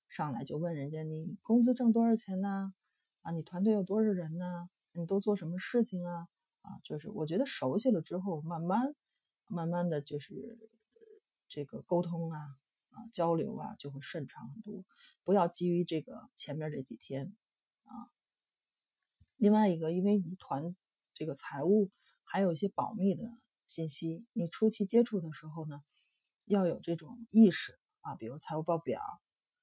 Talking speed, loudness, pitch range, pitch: 240 characters per minute, -34 LUFS, 165-210 Hz, 180 Hz